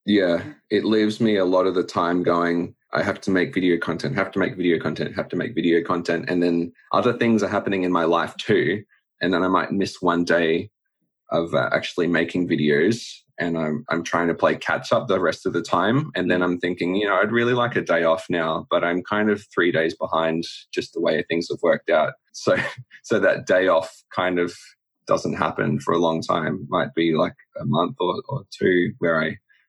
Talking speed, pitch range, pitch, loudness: 225 wpm, 85-95 Hz, 85 Hz, -22 LUFS